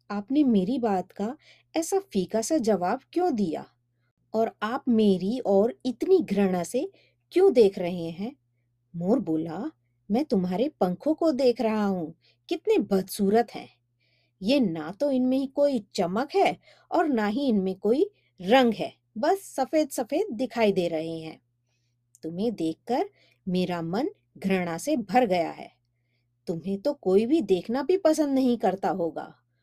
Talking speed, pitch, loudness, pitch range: 150 wpm, 215 Hz, -26 LUFS, 170-270 Hz